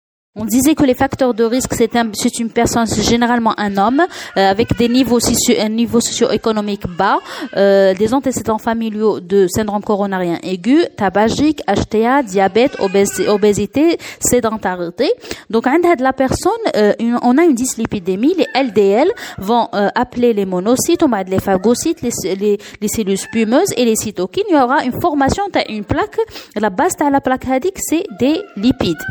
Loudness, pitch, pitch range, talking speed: -15 LUFS, 235 Hz, 210-270 Hz, 175 wpm